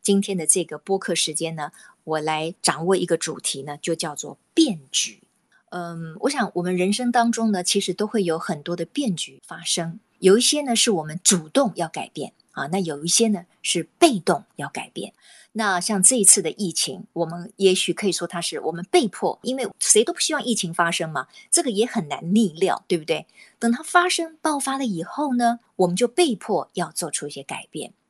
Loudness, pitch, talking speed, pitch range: -22 LUFS, 190 Hz, 290 characters per minute, 170-235 Hz